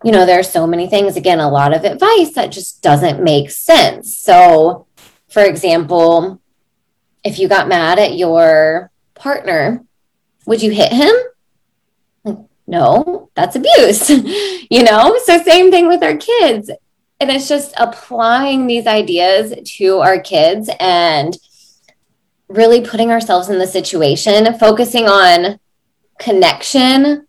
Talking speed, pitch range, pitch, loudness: 135 wpm, 185-285 Hz, 220 Hz, -11 LUFS